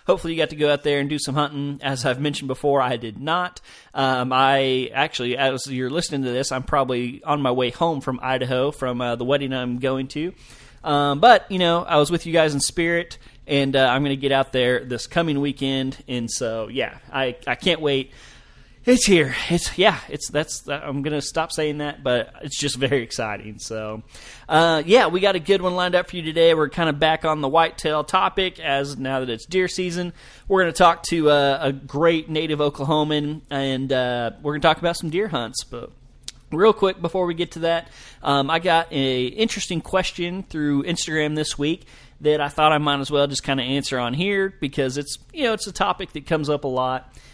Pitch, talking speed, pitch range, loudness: 145 Hz, 230 wpm, 135-165 Hz, -21 LUFS